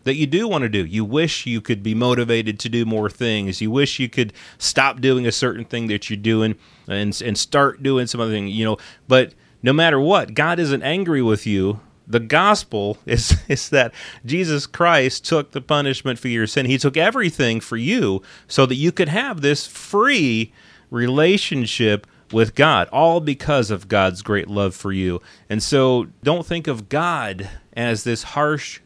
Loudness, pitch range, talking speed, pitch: -19 LUFS, 110-145 Hz, 190 wpm, 120 Hz